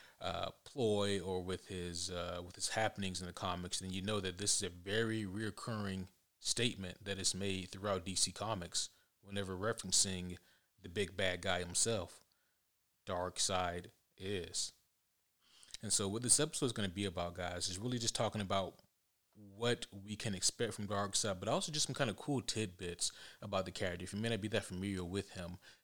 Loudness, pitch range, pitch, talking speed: -38 LUFS, 90-110 Hz, 100 Hz, 185 wpm